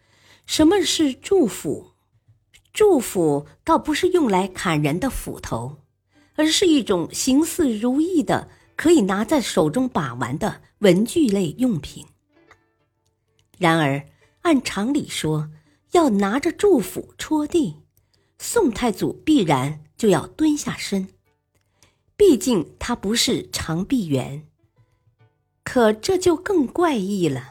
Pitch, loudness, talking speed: 200 Hz, -20 LUFS, 170 characters per minute